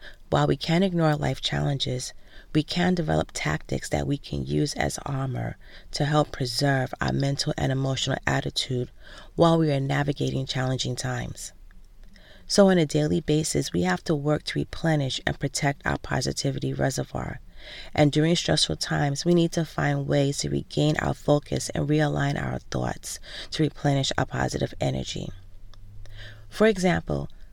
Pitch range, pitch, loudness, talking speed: 90-150 Hz, 135 Hz, -25 LUFS, 155 wpm